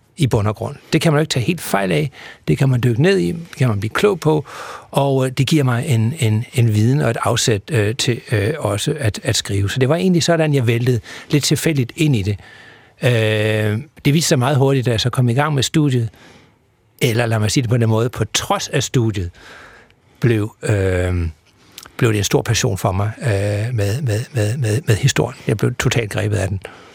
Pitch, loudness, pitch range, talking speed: 120 Hz, -18 LUFS, 110-145 Hz, 225 wpm